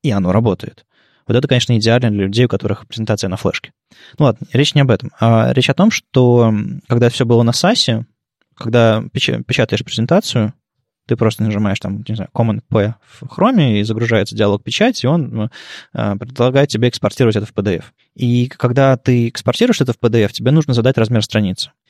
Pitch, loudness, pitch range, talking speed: 115 Hz, -15 LUFS, 110-130 Hz, 185 wpm